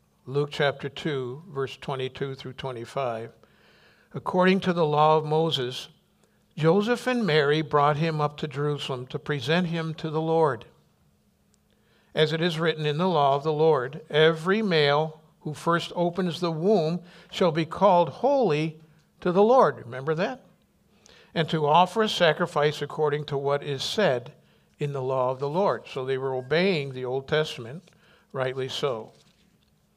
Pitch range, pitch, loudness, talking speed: 140-175 Hz, 155 Hz, -25 LUFS, 155 wpm